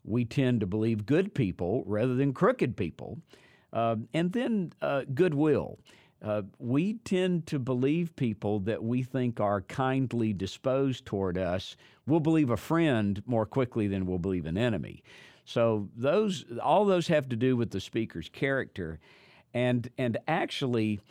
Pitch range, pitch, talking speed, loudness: 105-145 Hz, 125 Hz, 155 wpm, -29 LUFS